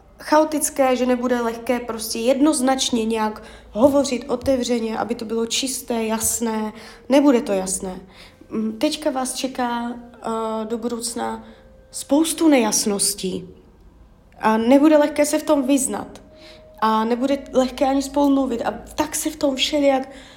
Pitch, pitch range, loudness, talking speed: 250 Hz, 225-275 Hz, -20 LUFS, 125 wpm